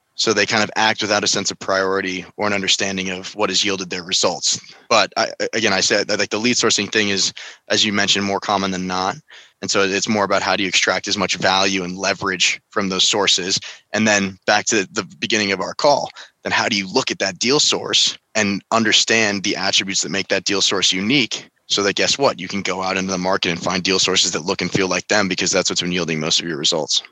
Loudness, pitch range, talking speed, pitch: -17 LUFS, 95-100 Hz, 250 wpm, 95 Hz